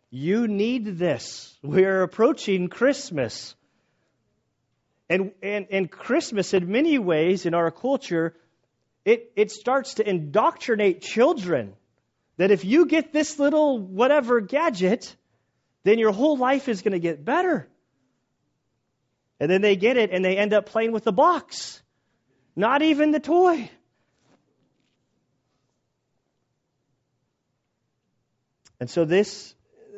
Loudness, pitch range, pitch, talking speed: -22 LUFS, 175-275 Hz, 210 Hz, 120 wpm